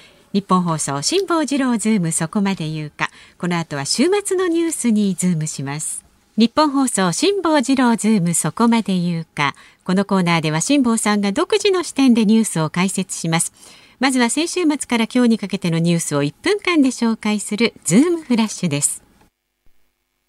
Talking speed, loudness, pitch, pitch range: 360 characters per minute, -18 LUFS, 215 Hz, 170-265 Hz